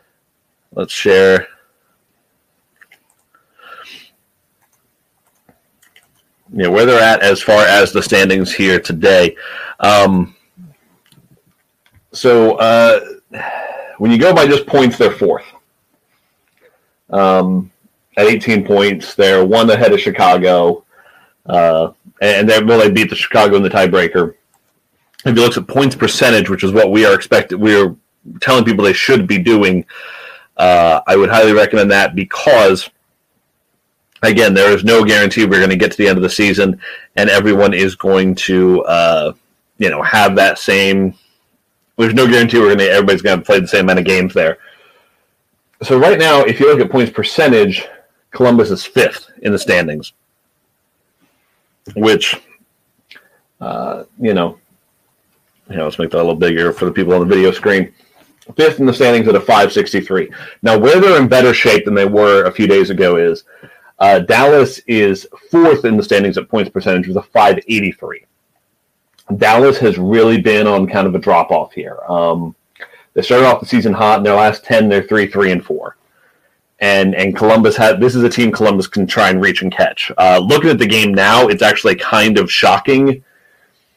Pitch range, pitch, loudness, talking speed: 95-120 Hz, 105 Hz, -11 LUFS, 170 wpm